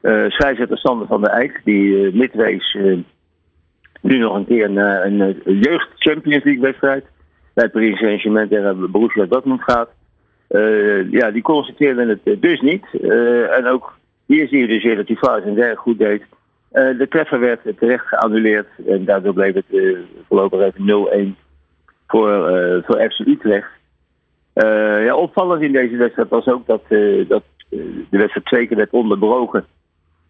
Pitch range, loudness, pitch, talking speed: 100-135 Hz, -16 LUFS, 110 Hz, 180 wpm